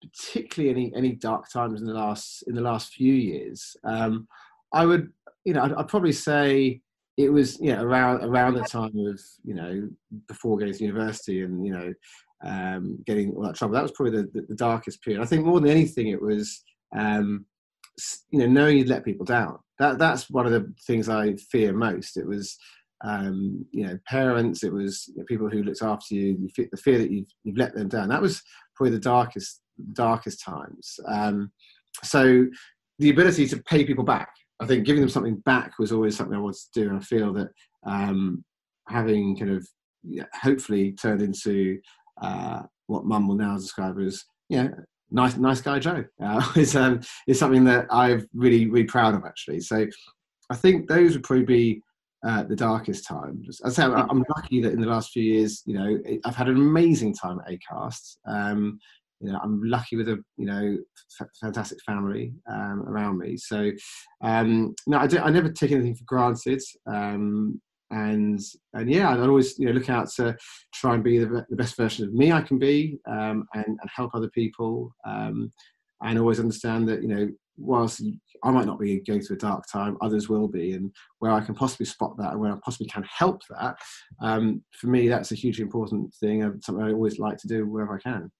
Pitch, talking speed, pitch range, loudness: 115 Hz, 205 wpm, 105-130 Hz, -25 LUFS